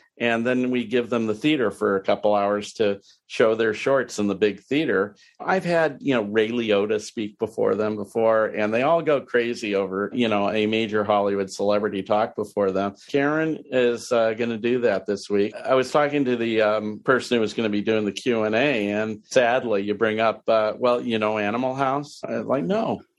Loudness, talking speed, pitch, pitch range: -23 LUFS, 215 wpm, 110 Hz, 105-125 Hz